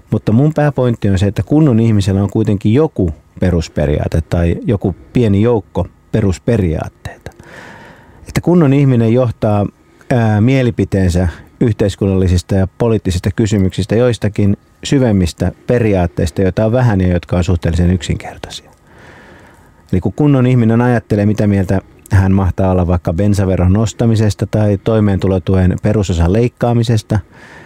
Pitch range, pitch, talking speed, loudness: 95-115 Hz, 105 Hz, 120 wpm, -14 LUFS